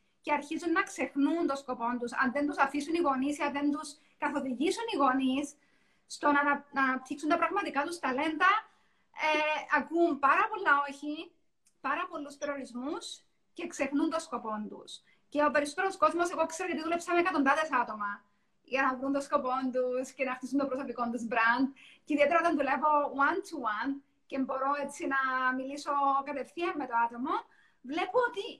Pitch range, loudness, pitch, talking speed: 265-320 Hz, -31 LUFS, 285 Hz, 170 wpm